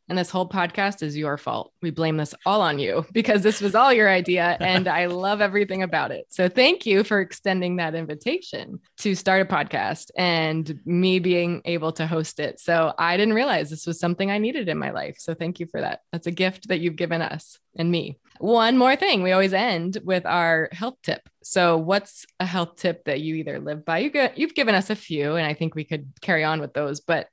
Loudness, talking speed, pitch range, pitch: -23 LUFS, 230 wpm, 165-200 Hz, 180 Hz